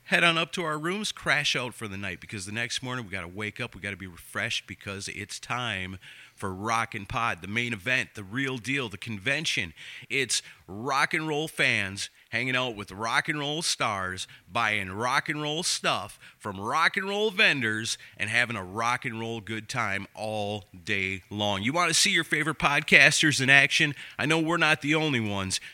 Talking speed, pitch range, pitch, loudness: 205 wpm, 105-150 Hz, 120 Hz, -26 LUFS